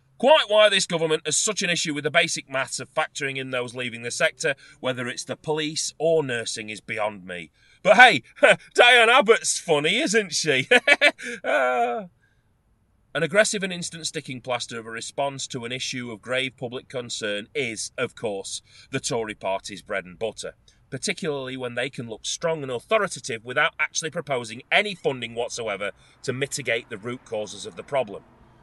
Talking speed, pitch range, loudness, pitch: 170 wpm, 120-165 Hz, -23 LUFS, 135 Hz